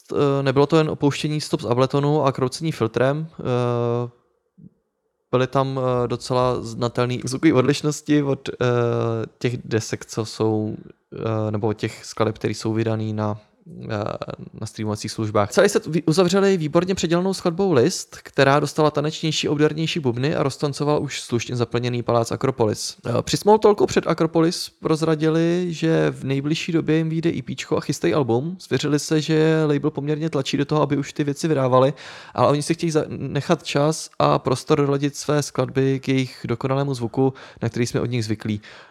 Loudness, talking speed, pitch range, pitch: -21 LUFS, 155 wpm, 120-155 Hz, 140 Hz